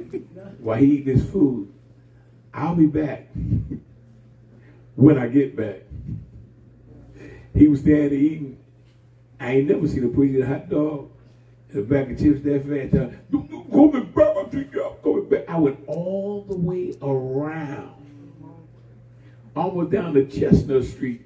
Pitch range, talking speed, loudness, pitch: 125-150 Hz, 120 wpm, -21 LUFS, 140 Hz